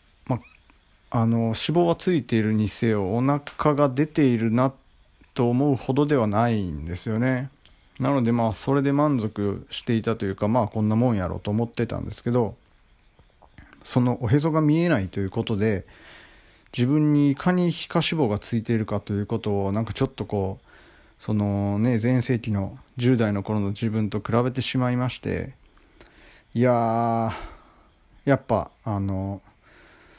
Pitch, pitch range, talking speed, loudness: 115 Hz, 105-130 Hz, 280 characters per minute, -24 LUFS